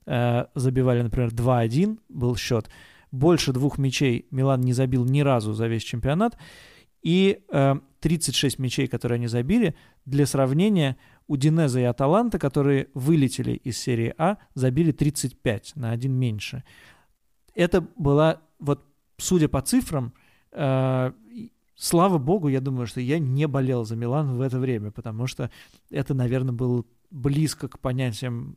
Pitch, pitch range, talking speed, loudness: 135 Hz, 125-150 Hz, 140 wpm, -24 LUFS